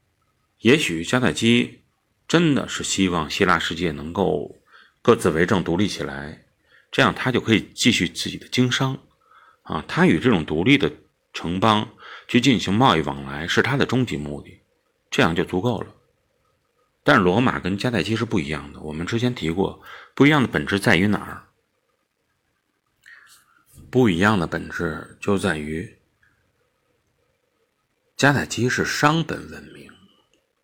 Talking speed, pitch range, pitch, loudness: 220 characters per minute, 80-115 Hz, 95 Hz, -21 LUFS